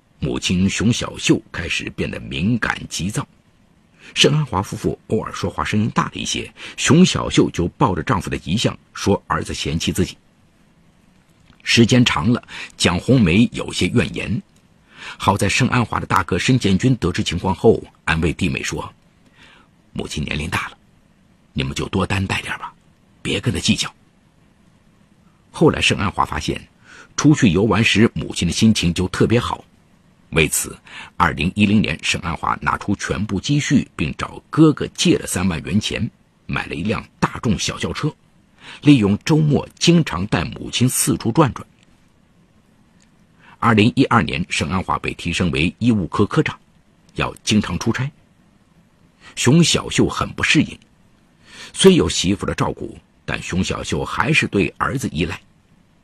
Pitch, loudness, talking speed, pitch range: 110 Hz, -18 LUFS, 230 characters per minute, 95-130 Hz